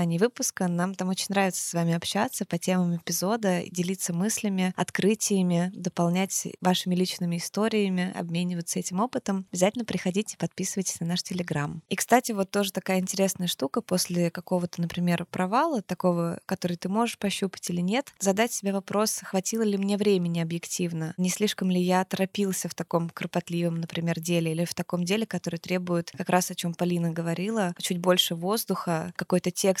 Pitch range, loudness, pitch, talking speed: 175-195 Hz, -27 LUFS, 185 Hz, 165 wpm